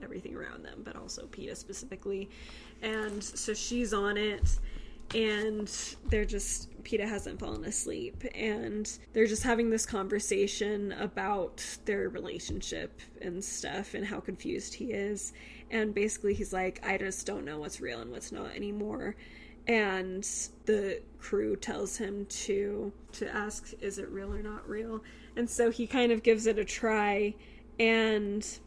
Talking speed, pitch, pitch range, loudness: 155 wpm, 210 Hz, 205-220 Hz, -33 LUFS